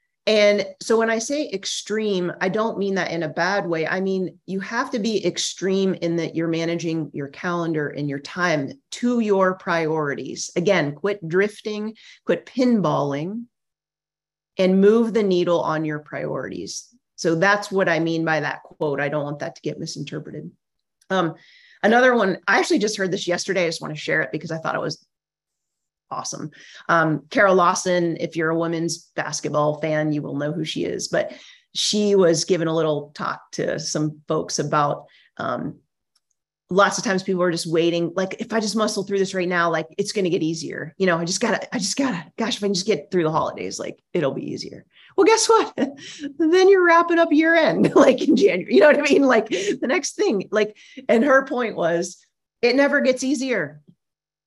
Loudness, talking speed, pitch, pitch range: -21 LUFS, 200 wpm, 185 Hz, 165-220 Hz